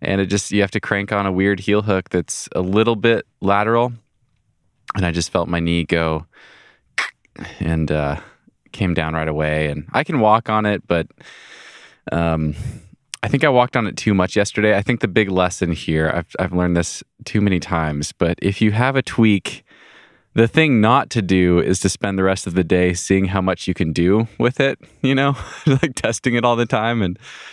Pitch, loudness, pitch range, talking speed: 100 Hz, -18 LUFS, 90-115 Hz, 210 wpm